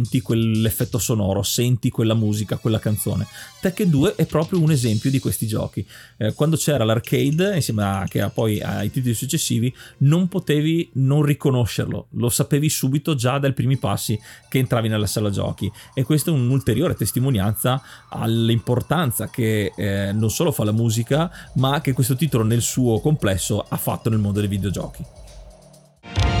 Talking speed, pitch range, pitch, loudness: 155 wpm, 110-140 Hz, 120 Hz, -21 LUFS